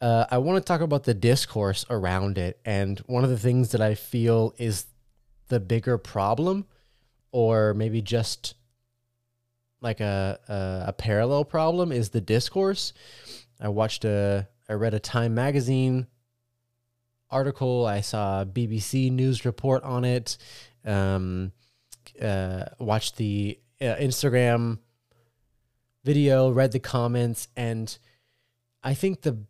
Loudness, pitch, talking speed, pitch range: -26 LUFS, 120 Hz, 130 wpm, 110-125 Hz